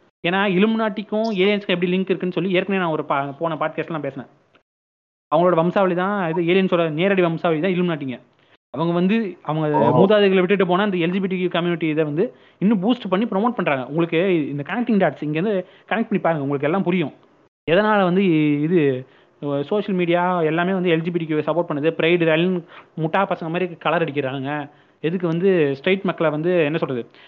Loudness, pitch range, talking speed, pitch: -20 LUFS, 155-190 Hz, 165 wpm, 175 Hz